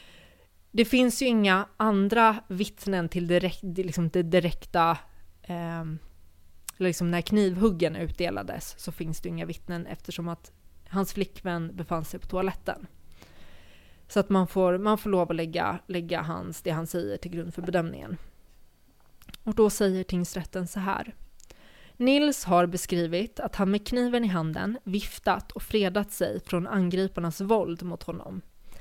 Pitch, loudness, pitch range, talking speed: 180 Hz, -28 LUFS, 170-200 Hz, 150 wpm